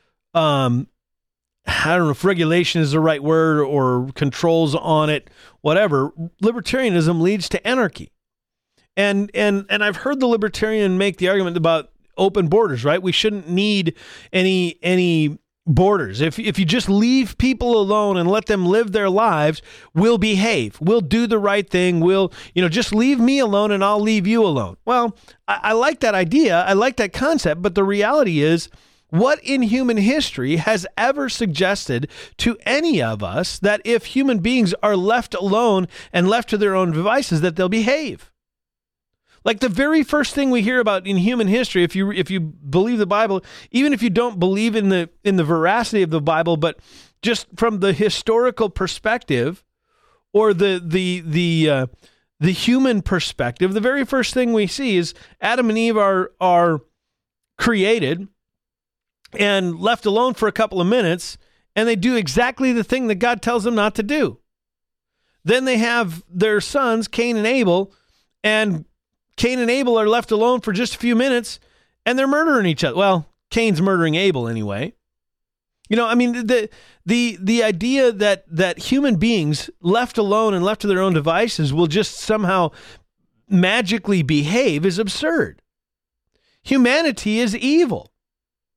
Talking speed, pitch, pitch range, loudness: 170 wpm, 205 Hz, 175-235 Hz, -18 LUFS